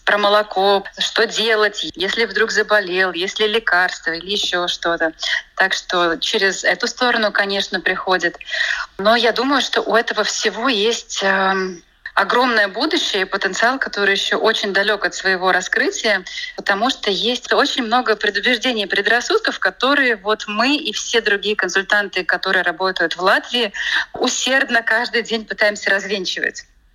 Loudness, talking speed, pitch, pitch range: -17 LUFS, 140 wpm, 210 Hz, 190-230 Hz